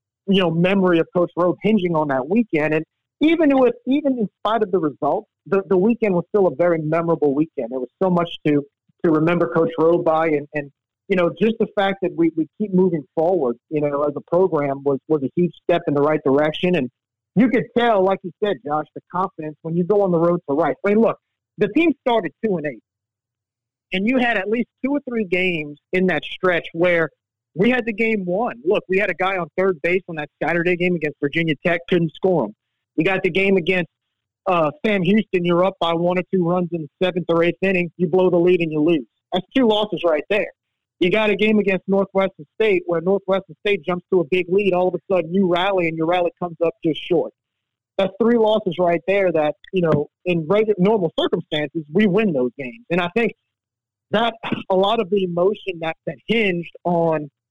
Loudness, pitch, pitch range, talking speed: -20 LUFS, 175 Hz, 155-195 Hz, 225 wpm